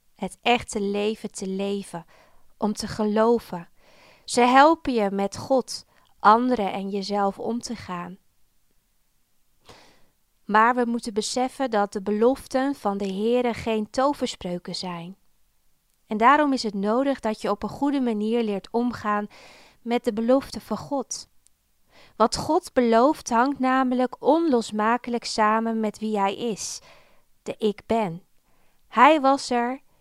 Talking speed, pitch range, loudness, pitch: 135 wpm, 205-250 Hz, -23 LUFS, 225 Hz